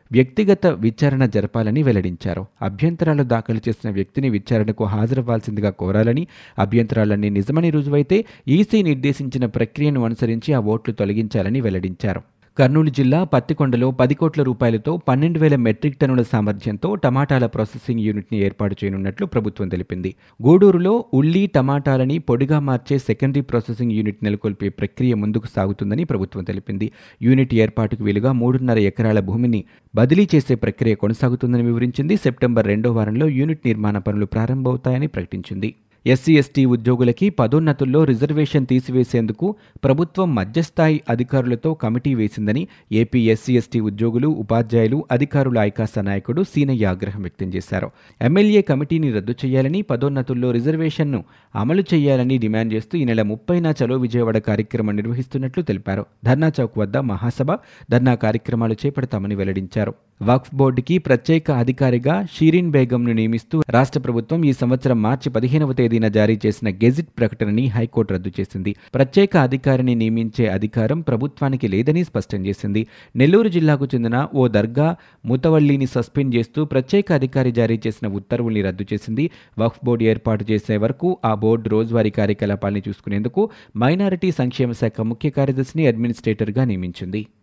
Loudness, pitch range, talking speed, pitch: -19 LUFS, 110-140 Hz, 125 wpm, 120 Hz